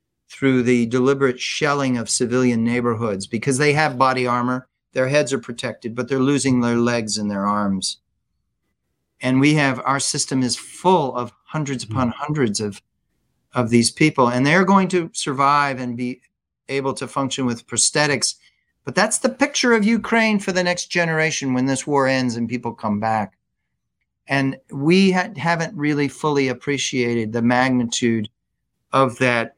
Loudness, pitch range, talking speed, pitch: -19 LUFS, 120-145 Hz, 160 wpm, 130 Hz